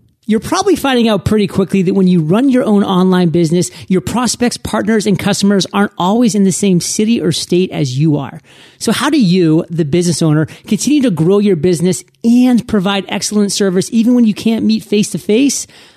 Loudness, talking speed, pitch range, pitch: -12 LUFS, 205 wpm, 180-225 Hz, 200 Hz